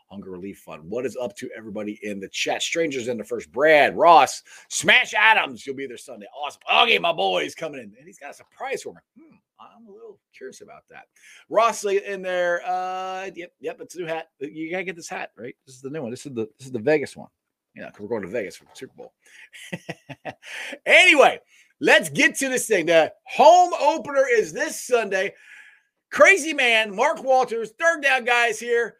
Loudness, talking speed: -19 LUFS, 215 wpm